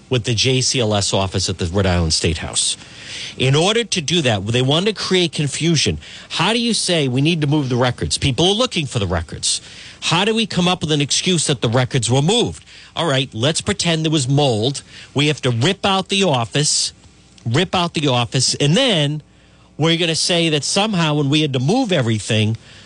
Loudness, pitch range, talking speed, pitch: -17 LUFS, 120-170 Hz, 210 wpm, 145 Hz